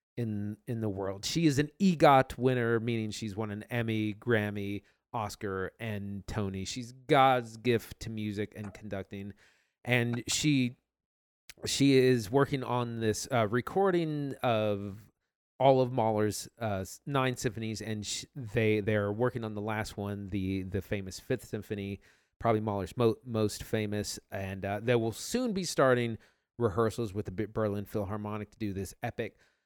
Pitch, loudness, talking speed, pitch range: 110 Hz, -31 LUFS, 155 wpm, 105-125 Hz